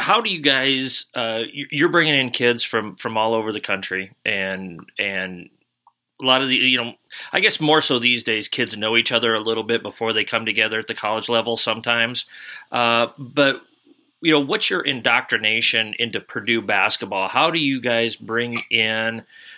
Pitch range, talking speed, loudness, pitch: 110-130 Hz, 185 wpm, -19 LUFS, 115 Hz